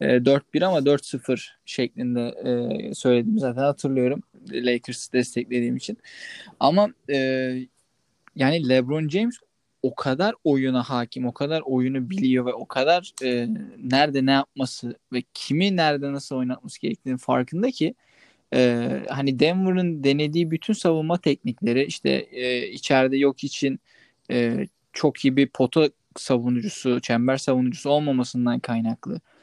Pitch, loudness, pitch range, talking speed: 130 Hz, -23 LUFS, 125-150 Hz, 110 wpm